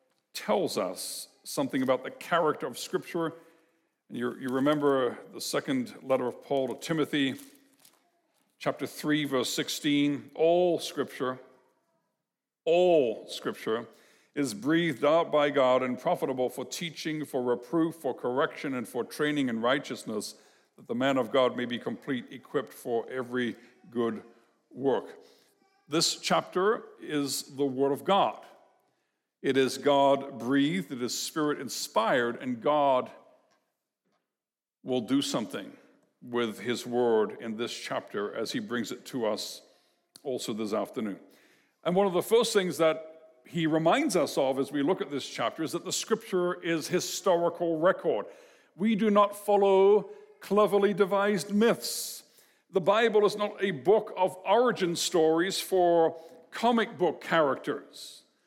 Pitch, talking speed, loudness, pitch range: 160 Hz, 140 wpm, -29 LUFS, 135-195 Hz